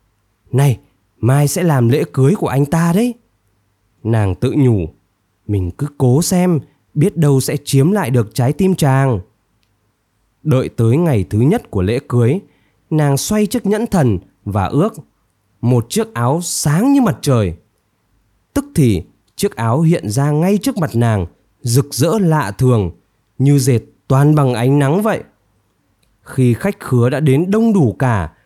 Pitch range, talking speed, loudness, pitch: 105-155 Hz, 160 wpm, -15 LUFS, 130 Hz